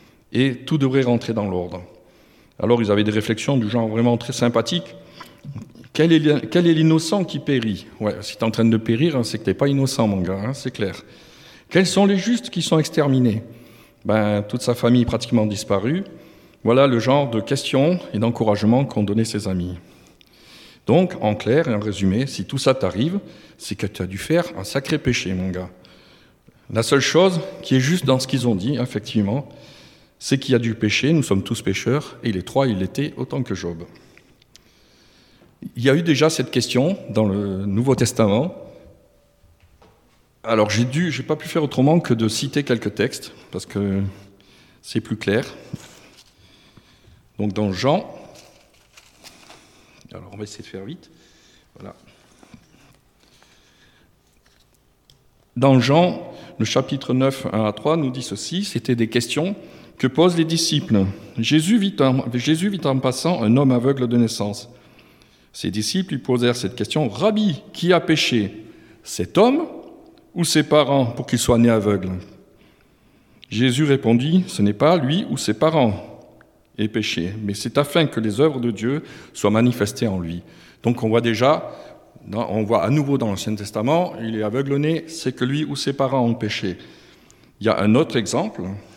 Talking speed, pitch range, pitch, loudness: 175 wpm, 105-145 Hz, 120 Hz, -20 LUFS